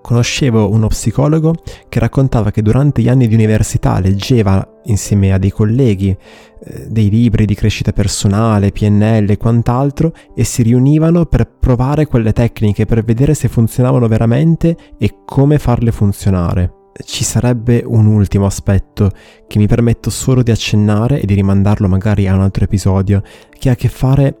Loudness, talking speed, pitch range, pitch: -13 LUFS, 155 wpm, 105-125 Hz, 110 Hz